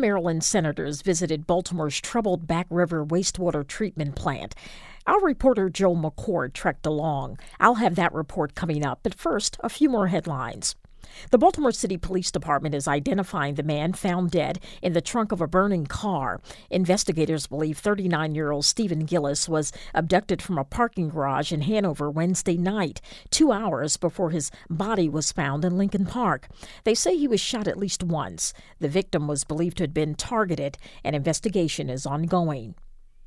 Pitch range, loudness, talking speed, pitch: 150-195 Hz, -25 LUFS, 170 wpm, 170 Hz